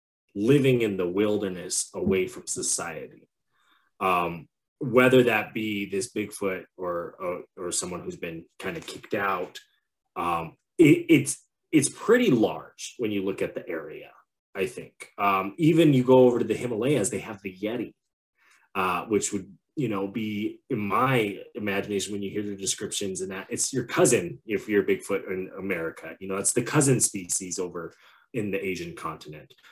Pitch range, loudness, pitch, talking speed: 95-125 Hz, -26 LUFS, 100 Hz, 170 wpm